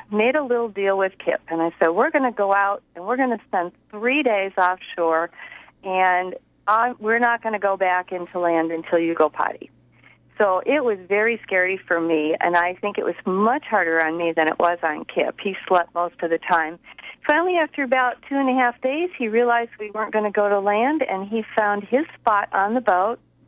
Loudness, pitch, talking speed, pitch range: -21 LUFS, 200 Hz, 225 wpm, 175-235 Hz